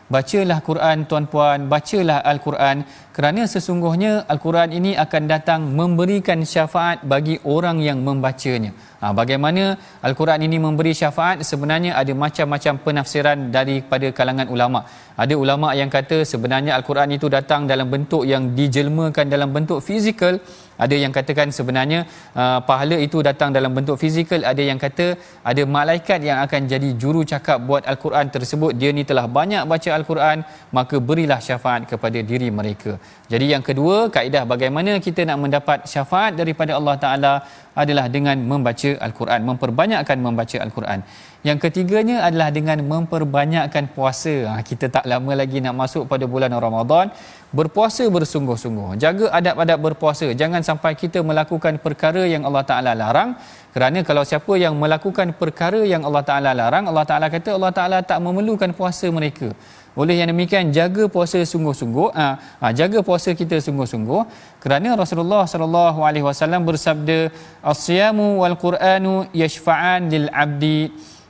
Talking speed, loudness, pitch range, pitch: 140 wpm, -19 LUFS, 135-170 Hz, 150 Hz